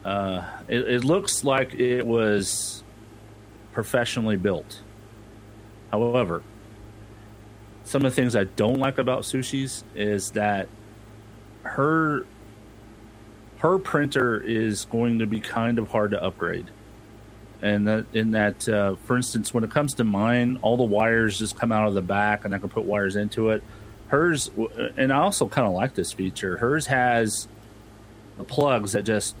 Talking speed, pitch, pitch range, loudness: 155 wpm, 110 Hz, 105-120 Hz, -24 LUFS